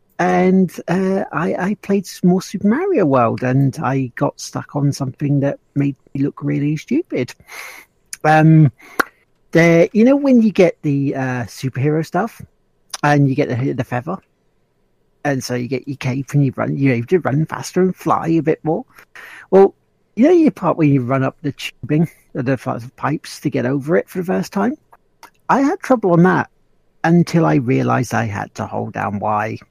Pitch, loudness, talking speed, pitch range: 145 Hz, -17 LUFS, 190 wpm, 130-180 Hz